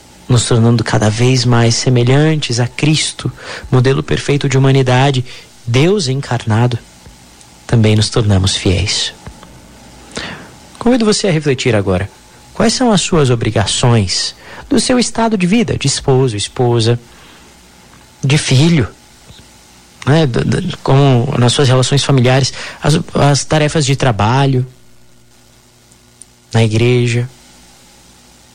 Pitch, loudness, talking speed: 120 Hz, -13 LUFS, 105 wpm